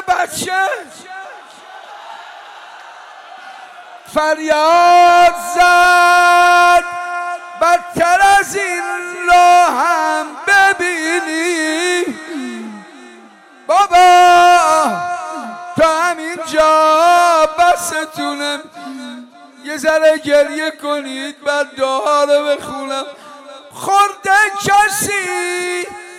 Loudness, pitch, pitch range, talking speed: -12 LUFS, 350 Hz, 310-360 Hz, 55 wpm